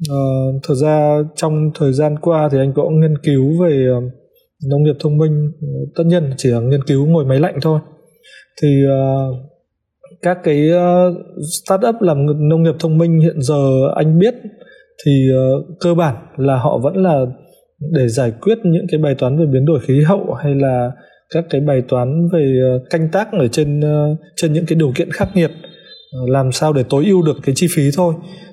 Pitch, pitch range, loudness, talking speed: 150 Hz, 135-170 Hz, -15 LUFS, 200 wpm